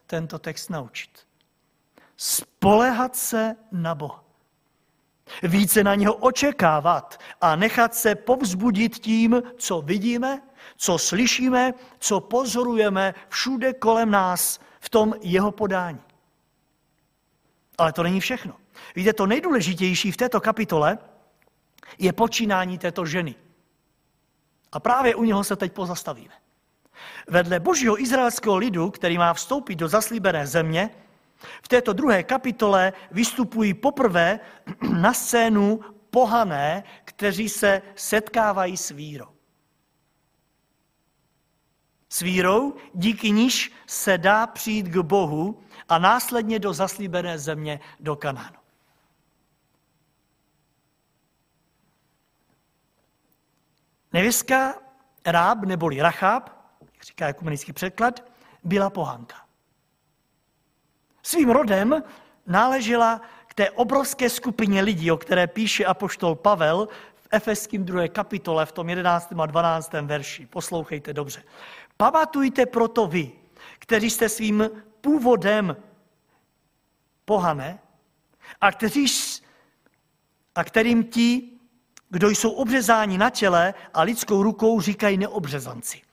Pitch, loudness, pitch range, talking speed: 205 Hz, -22 LUFS, 170-235 Hz, 100 wpm